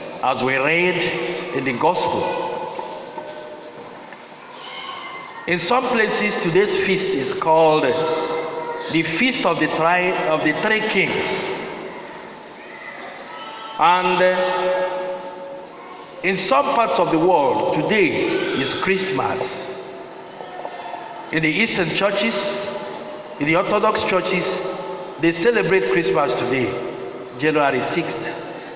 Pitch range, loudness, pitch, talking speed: 165-215 Hz, -19 LUFS, 180 Hz, 95 wpm